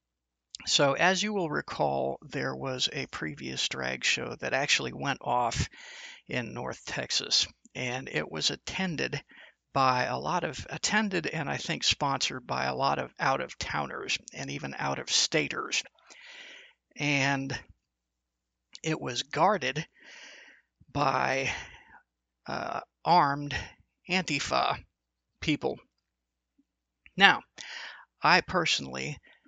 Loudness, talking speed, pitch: -29 LUFS, 110 wpm, 130 Hz